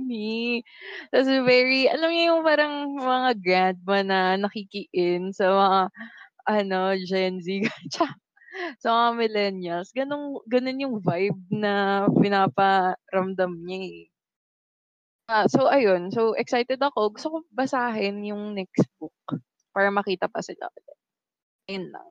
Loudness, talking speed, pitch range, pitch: -24 LUFS, 130 wpm, 190-255 Hz, 205 Hz